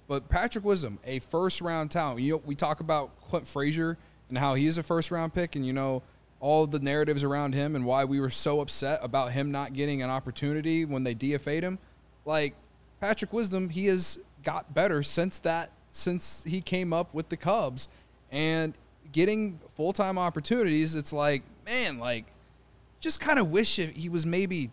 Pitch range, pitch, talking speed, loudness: 140-180 Hz, 155 Hz, 180 wpm, -29 LUFS